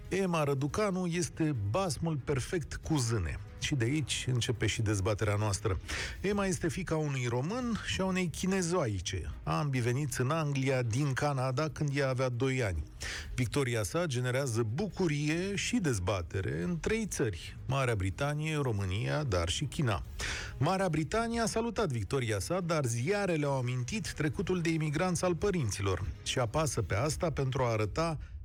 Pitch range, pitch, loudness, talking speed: 110-165 Hz, 135 Hz, -32 LUFS, 150 wpm